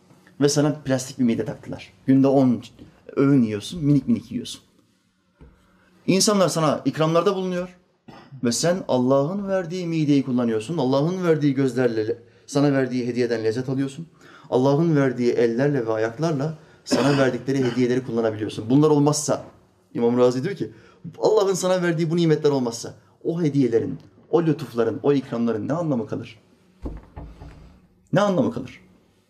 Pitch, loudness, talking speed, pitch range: 135 Hz, -22 LUFS, 130 wpm, 120-155 Hz